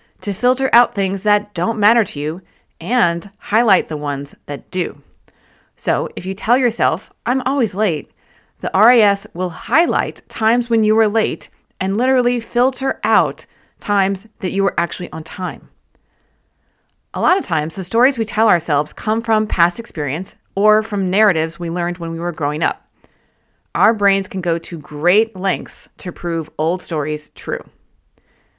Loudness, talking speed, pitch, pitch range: -18 LUFS, 165 wpm, 195 Hz, 170-225 Hz